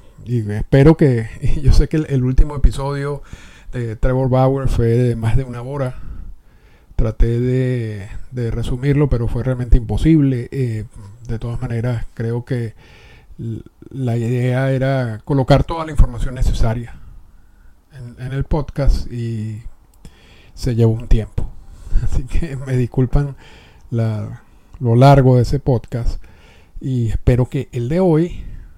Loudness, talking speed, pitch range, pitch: -18 LUFS, 135 wpm, 115-135 Hz, 125 Hz